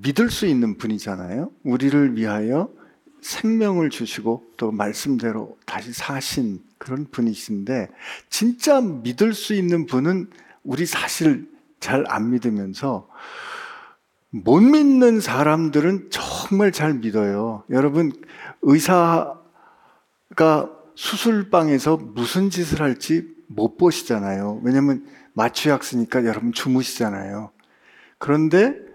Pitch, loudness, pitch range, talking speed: 150 Hz, -20 LUFS, 120-195 Hz, 235 characters per minute